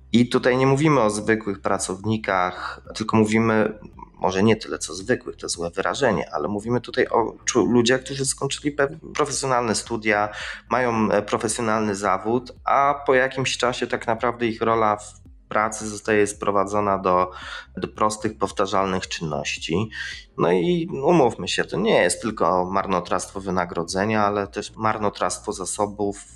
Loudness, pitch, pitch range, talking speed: -22 LUFS, 110 Hz, 100-120 Hz, 140 wpm